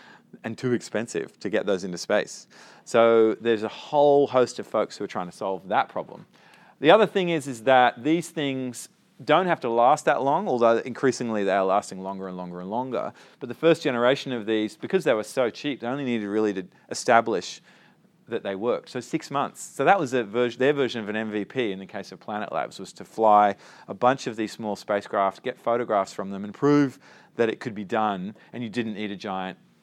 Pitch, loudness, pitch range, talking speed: 115 Hz, -24 LUFS, 105-130 Hz, 225 wpm